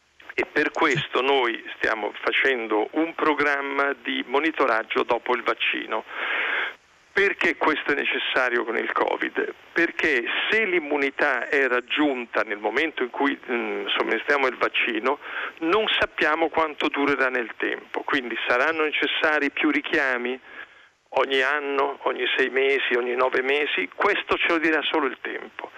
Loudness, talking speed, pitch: -23 LUFS, 135 wpm, 150 Hz